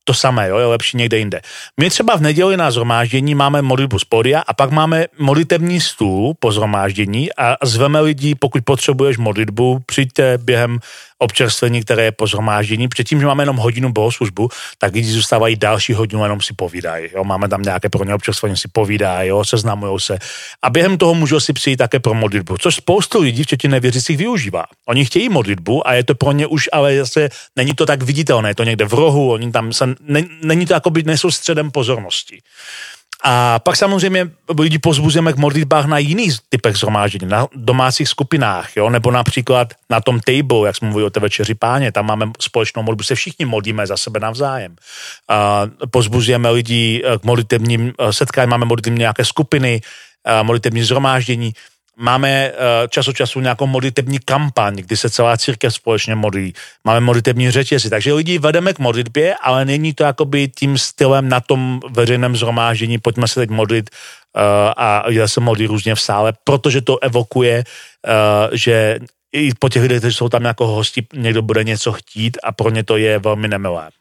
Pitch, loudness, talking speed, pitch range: 120 Hz, -15 LUFS, 180 wpm, 110-140 Hz